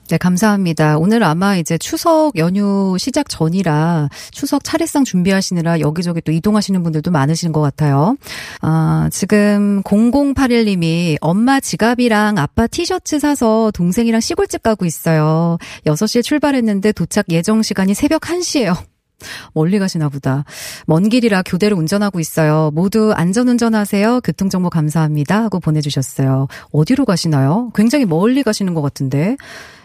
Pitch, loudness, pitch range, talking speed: 195 Hz, -15 LUFS, 160-230 Hz, 335 characters per minute